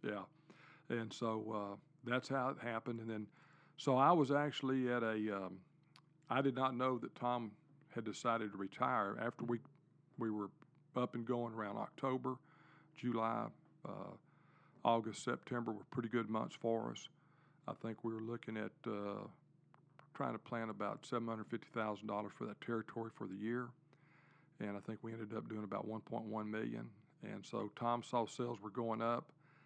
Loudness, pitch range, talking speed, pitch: -42 LUFS, 110-135 Hz, 180 wpm, 120 Hz